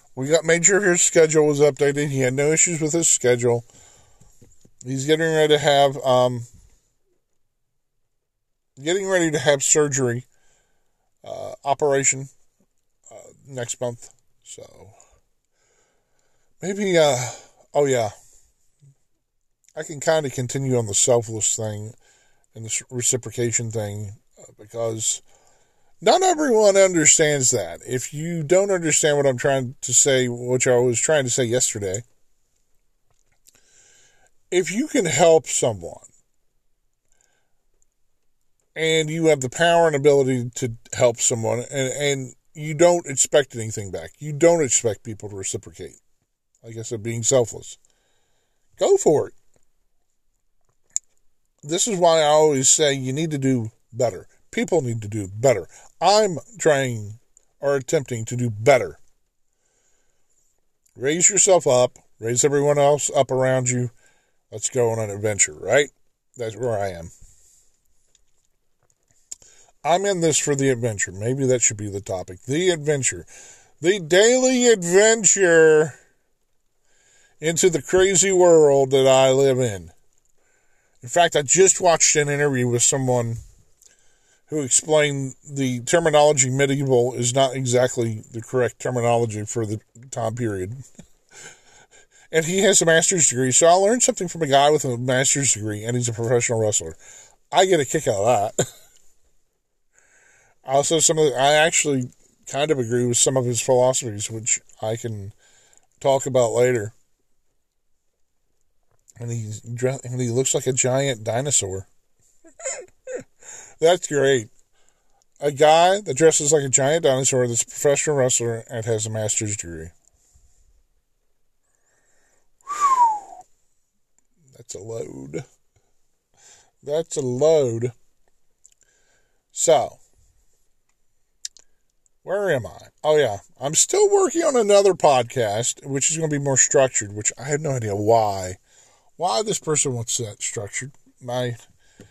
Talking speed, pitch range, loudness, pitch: 130 wpm, 120-155 Hz, -19 LUFS, 135 Hz